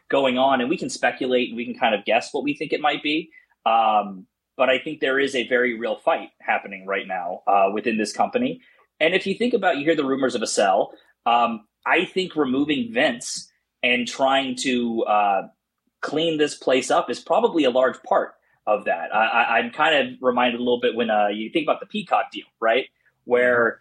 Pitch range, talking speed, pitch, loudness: 120-160 Hz, 215 wpm, 130 Hz, -22 LUFS